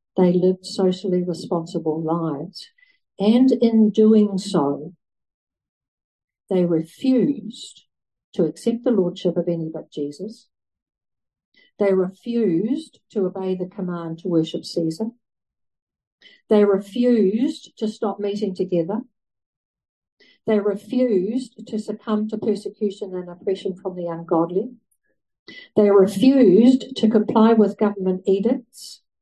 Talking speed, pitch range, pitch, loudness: 105 wpm, 180-230 Hz, 205 Hz, -21 LUFS